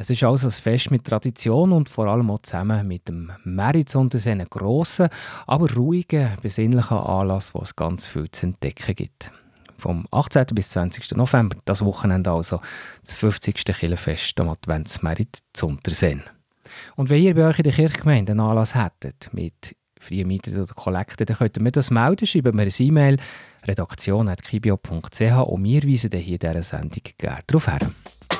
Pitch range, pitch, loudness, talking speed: 95-130 Hz, 110 Hz, -21 LUFS, 165 wpm